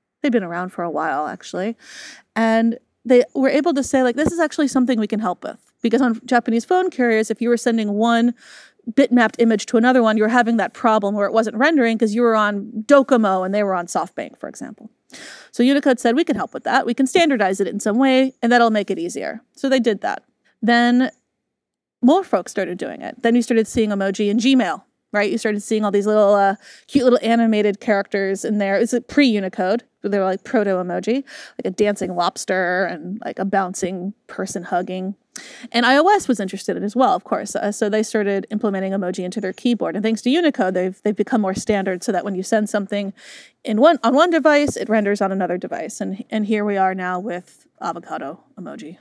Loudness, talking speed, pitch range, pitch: -19 LUFS, 220 wpm, 200-250 Hz, 225 Hz